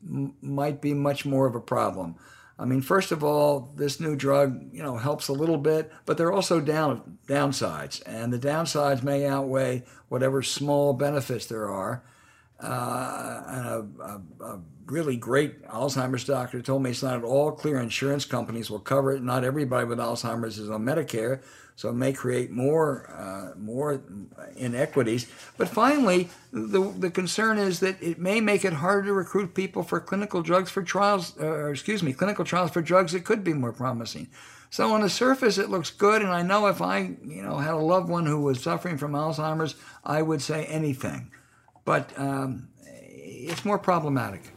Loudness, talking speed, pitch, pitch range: -26 LUFS, 185 wpm, 145 Hz, 130-175 Hz